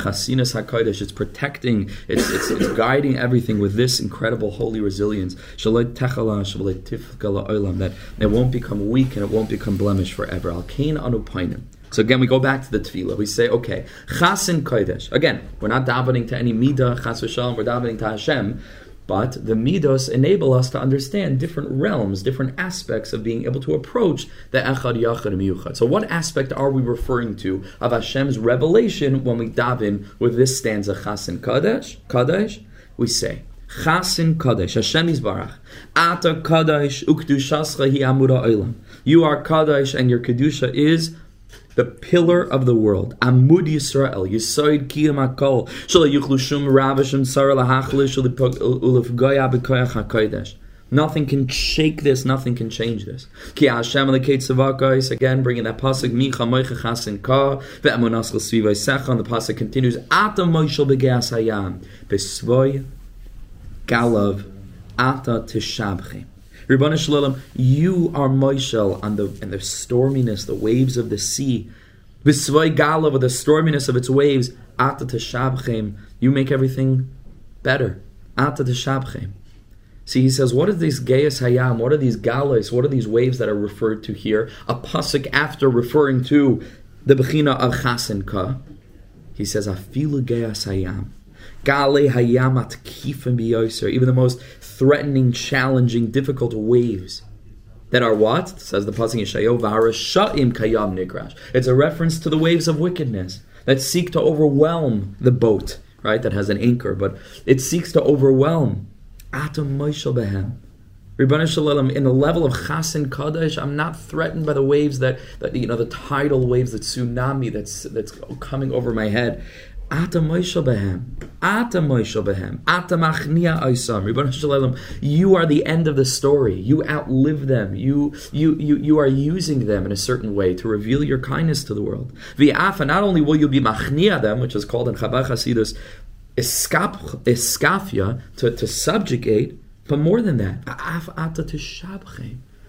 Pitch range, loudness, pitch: 110-140 Hz, -19 LUFS, 125 Hz